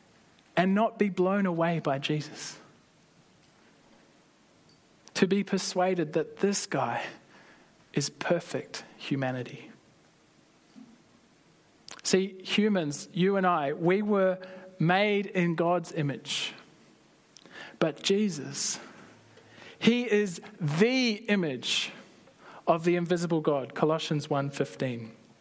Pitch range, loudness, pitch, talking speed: 150-195 Hz, -28 LUFS, 175 Hz, 90 wpm